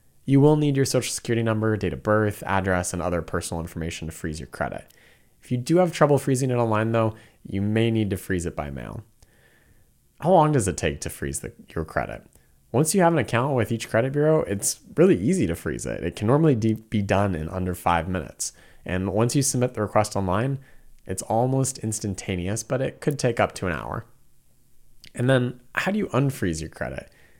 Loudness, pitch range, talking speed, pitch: -24 LUFS, 95-130 Hz, 210 wpm, 110 Hz